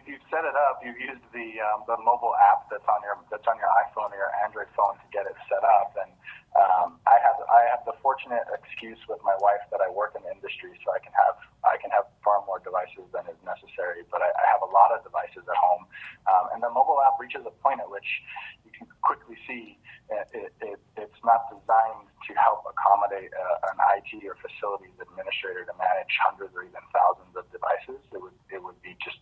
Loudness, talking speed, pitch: -25 LUFS, 230 wpm, 135 Hz